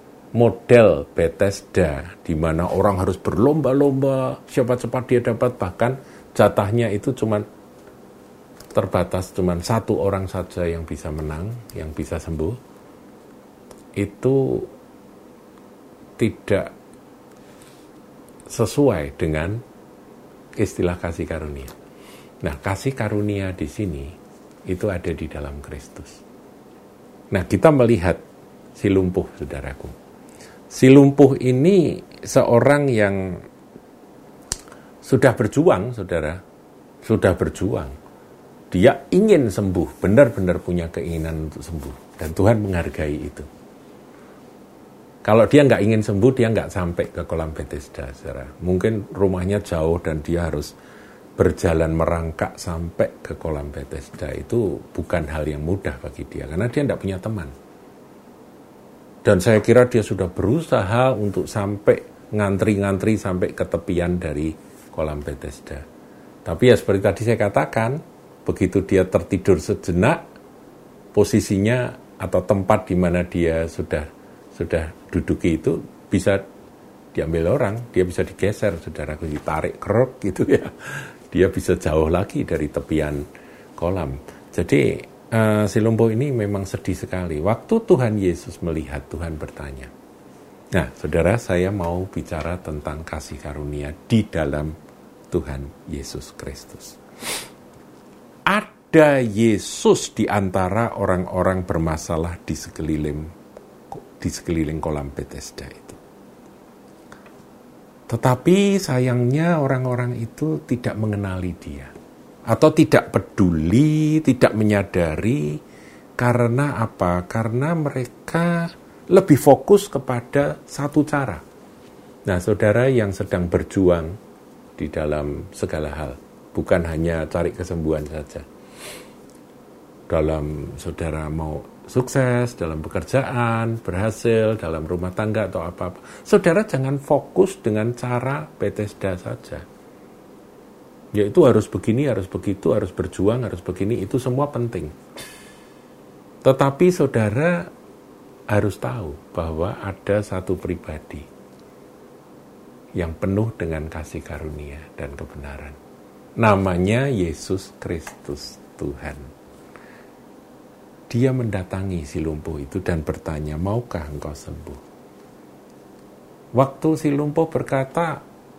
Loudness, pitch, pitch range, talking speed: -21 LUFS, 95 Hz, 80-120 Hz, 105 wpm